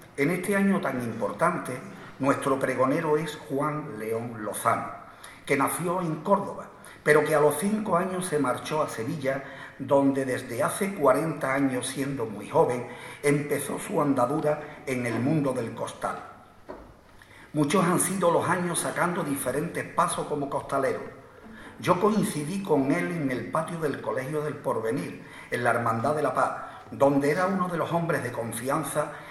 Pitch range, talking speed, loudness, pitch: 135-170 Hz, 155 wpm, -27 LUFS, 150 Hz